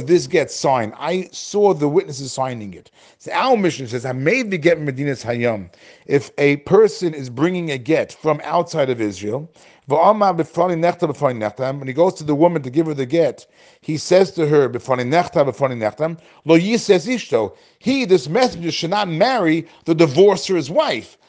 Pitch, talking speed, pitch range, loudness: 160 Hz, 160 wpm, 135-180 Hz, -18 LUFS